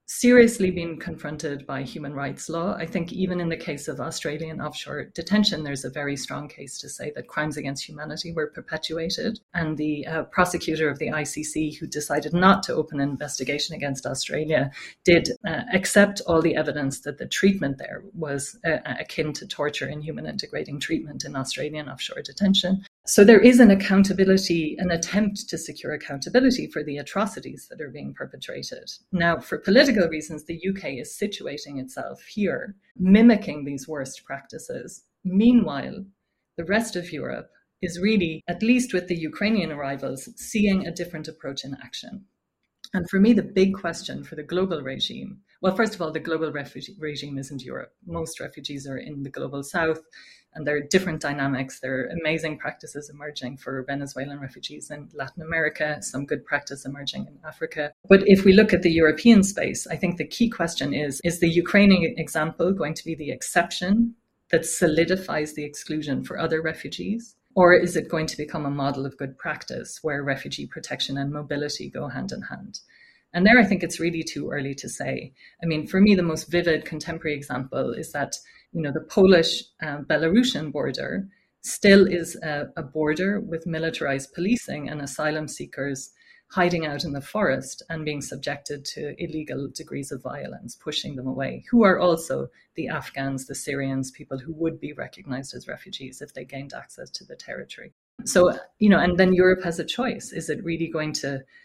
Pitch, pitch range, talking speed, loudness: 160 Hz, 145-185 Hz, 180 wpm, -24 LUFS